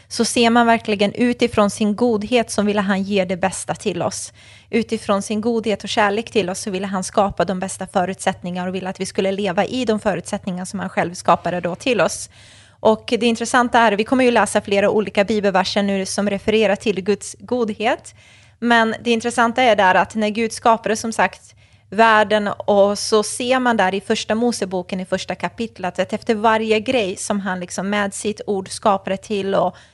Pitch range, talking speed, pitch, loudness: 195-225 Hz, 195 wpm, 210 Hz, -19 LUFS